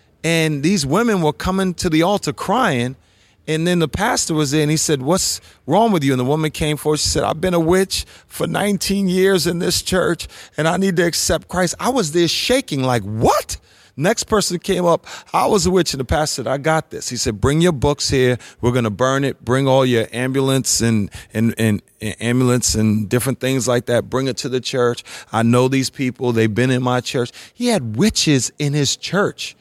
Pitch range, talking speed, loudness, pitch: 125-175 Hz, 225 wpm, -18 LUFS, 145 Hz